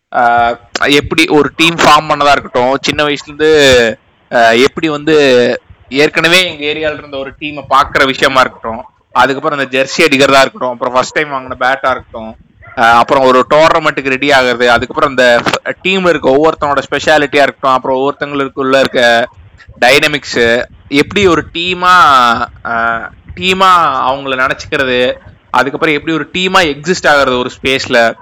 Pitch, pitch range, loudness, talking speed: 135 Hz, 125-150 Hz, -10 LUFS, 125 wpm